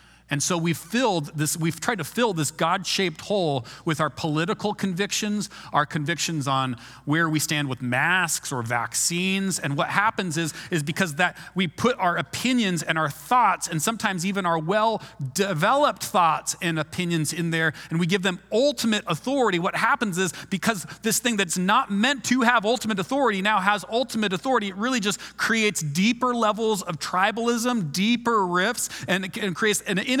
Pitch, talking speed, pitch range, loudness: 190 Hz, 175 wpm, 165-220 Hz, -24 LUFS